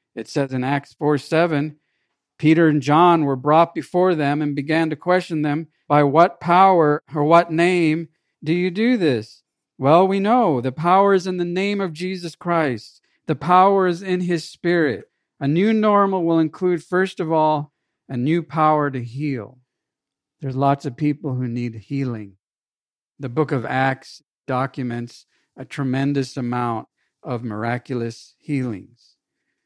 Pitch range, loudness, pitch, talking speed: 135-170 Hz, -19 LUFS, 150 Hz, 155 wpm